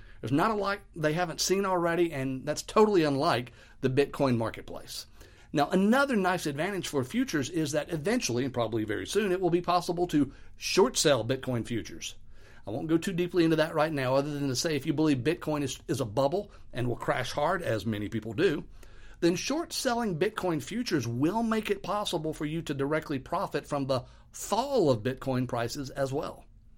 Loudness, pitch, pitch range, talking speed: -29 LUFS, 150 Hz, 130-180 Hz, 195 wpm